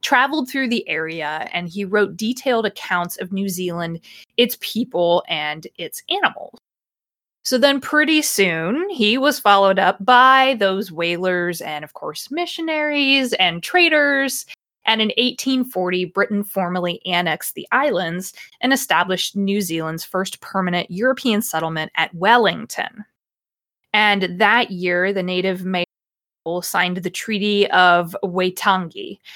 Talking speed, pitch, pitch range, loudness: 130 wpm, 200 Hz, 180-250 Hz, -18 LUFS